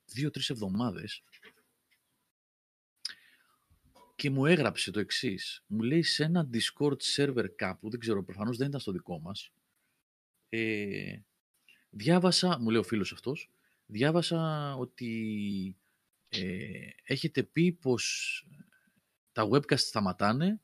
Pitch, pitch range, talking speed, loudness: 125 Hz, 105-150 Hz, 110 wpm, -31 LUFS